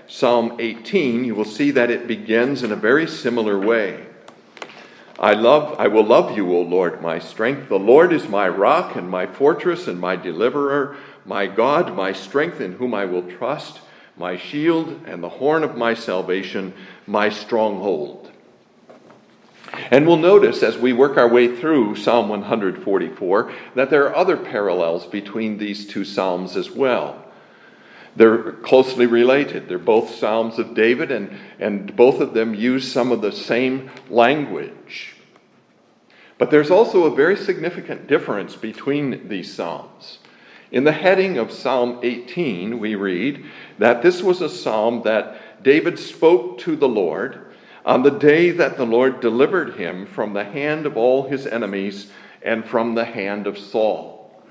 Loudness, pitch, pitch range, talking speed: -19 LUFS, 120 Hz, 110-145 Hz, 160 wpm